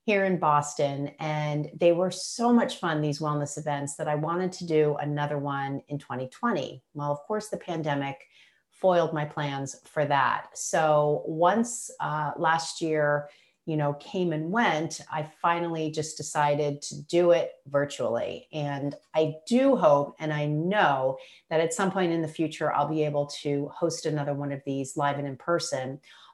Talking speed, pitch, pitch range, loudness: 175 wpm, 150 Hz, 145-170 Hz, -27 LUFS